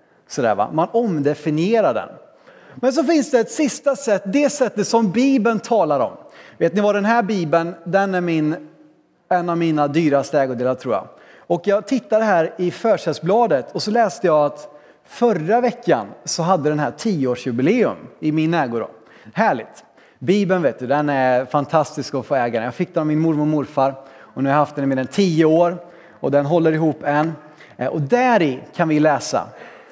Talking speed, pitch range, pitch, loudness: 185 wpm, 145-210 Hz, 165 Hz, -19 LUFS